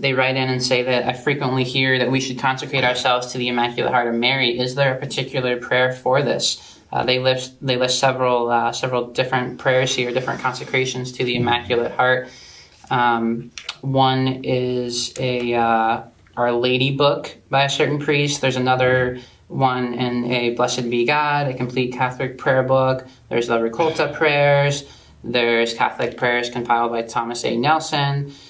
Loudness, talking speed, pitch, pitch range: -19 LUFS, 170 wpm, 125 Hz, 120-130 Hz